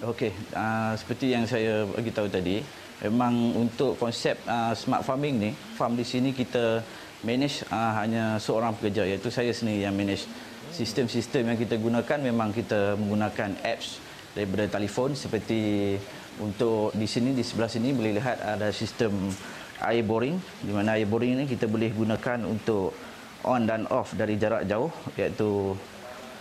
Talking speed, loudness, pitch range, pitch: 155 wpm, -28 LUFS, 105-120 Hz, 115 Hz